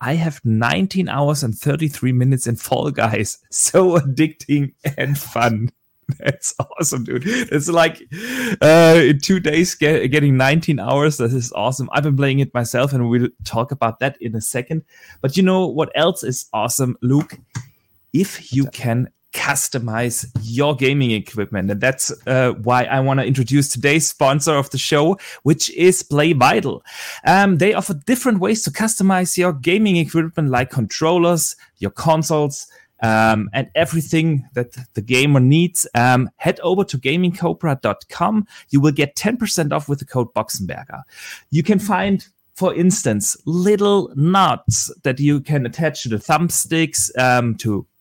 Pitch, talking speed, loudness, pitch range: 145 Hz, 155 wpm, -17 LUFS, 125-165 Hz